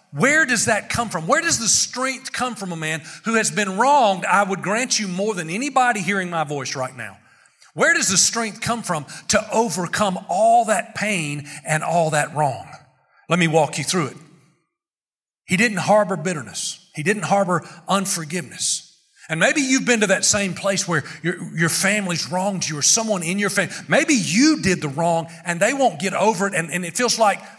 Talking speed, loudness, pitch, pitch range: 200 wpm, -19 LUFS, 195 Hz, 170-225 Hz